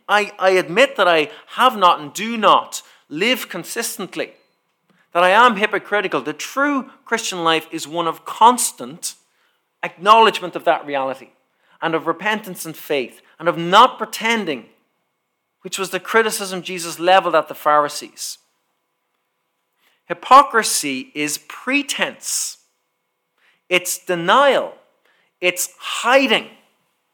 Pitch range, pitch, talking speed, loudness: 165-225 Hz, 185 Hz, 115 wpm, -17 LUFS